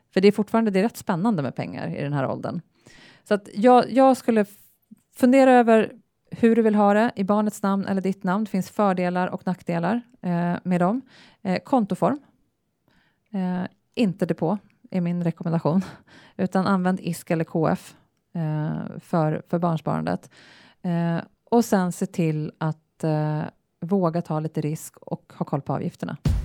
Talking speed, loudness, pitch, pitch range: 170 wpm, -23 LUFS, 185 Hz, 170-215 Hz